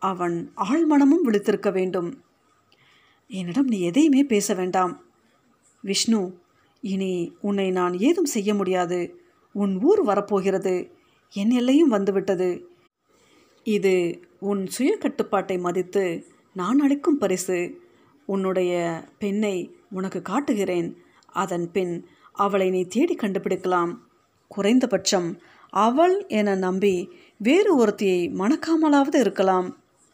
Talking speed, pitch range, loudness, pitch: 95 wpm, 185-245 Hz, -23 LUFS, 200 Hz